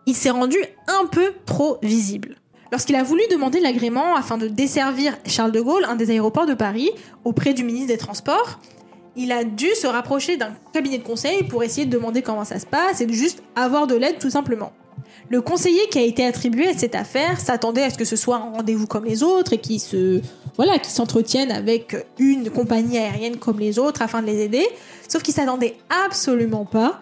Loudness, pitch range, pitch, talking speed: -20 LUFS, 225-290 Hz, 245 Hz, 210 wpm